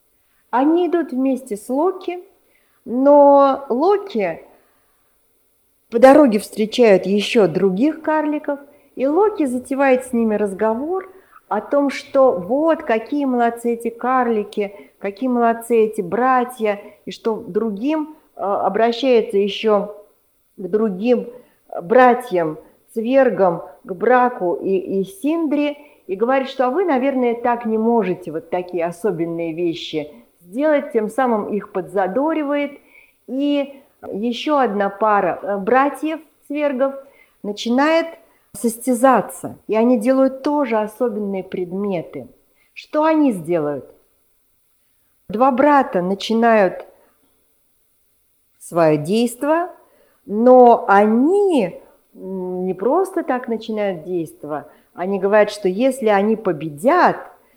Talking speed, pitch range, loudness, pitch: 100 wpm, 200-275 Hz, -18 LUFS, 235 Hz